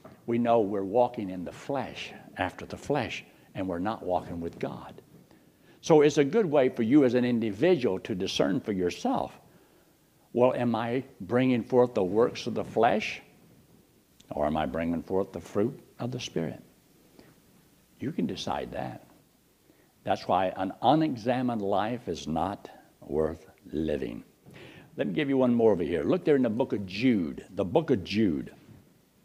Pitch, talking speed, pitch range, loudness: 115 Hz, 170 wpm, 95-125 Hz, -28 LUFS